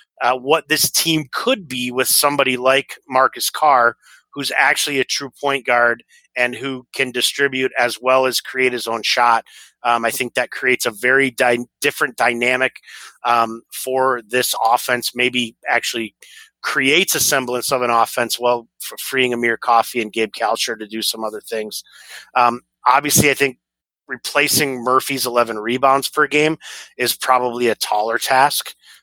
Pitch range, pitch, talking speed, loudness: 120-135 Hz, 125 Hz, 160 wpm, -17 LUFS